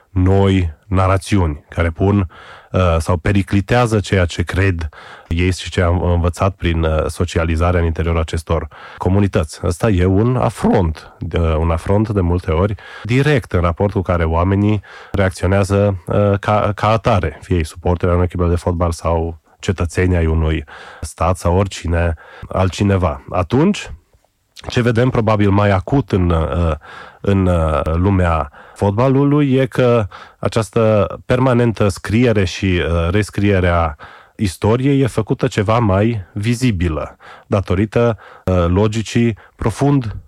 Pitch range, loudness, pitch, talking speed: 85-105 Hz, -16 LUFS, 95 Hz, 125 wpm